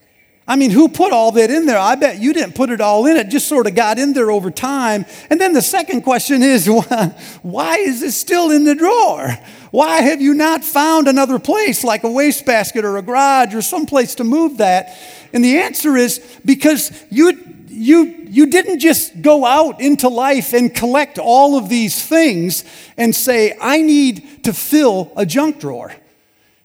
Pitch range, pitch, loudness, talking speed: 230-300 Hz, 265 Hz, -13 LUFS, 195 wpm